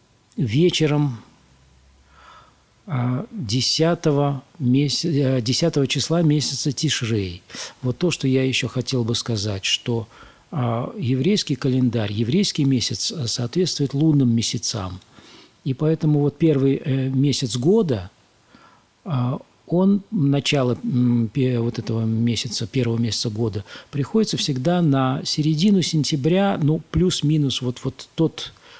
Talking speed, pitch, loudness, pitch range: 95 wpm, 130 Hz, -21 LUFS, 120-155 Hz